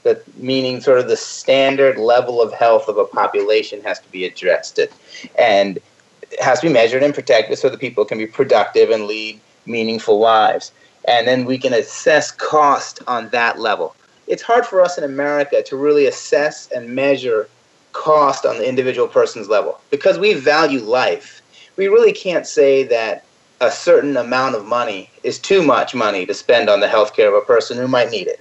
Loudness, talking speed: -16 LUFS, 190 wpm